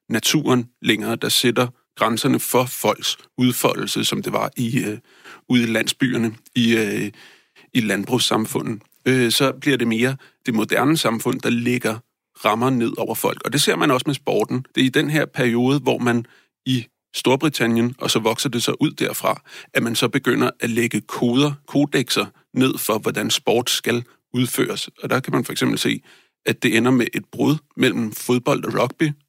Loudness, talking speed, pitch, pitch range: -20 LUFS, 180 wpm, 125 Hz, 115-130 Hz